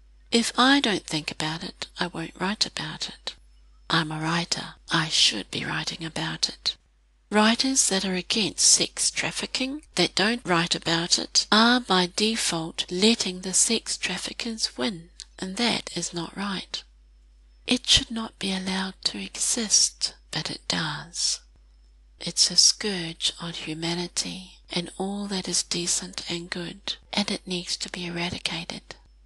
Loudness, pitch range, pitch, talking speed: -24 LUFS, 165-215 Hz, 180 Hz, 150 wpm